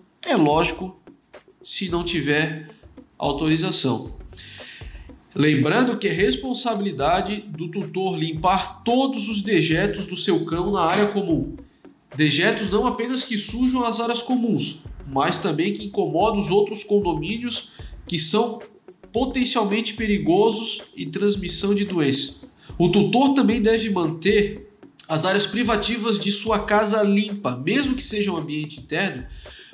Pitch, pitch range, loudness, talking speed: 205 Hz, 175-225 Hz, -21 LUFS, 125 wpm